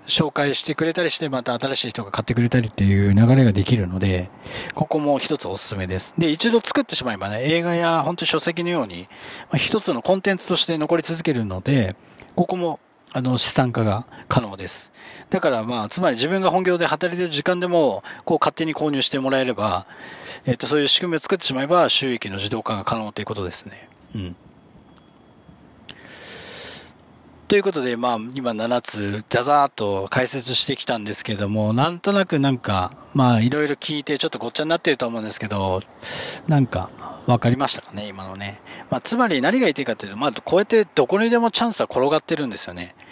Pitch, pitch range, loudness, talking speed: 130 Hz, 110-165 Hz, -21 LUFS, 410 characters per minute